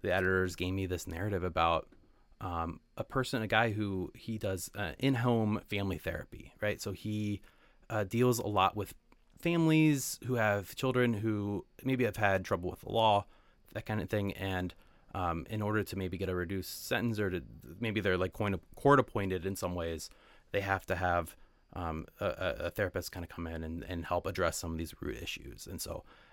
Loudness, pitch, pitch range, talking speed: -34 LUFS, 95 Hz, 90-110 Hz, 195 wpm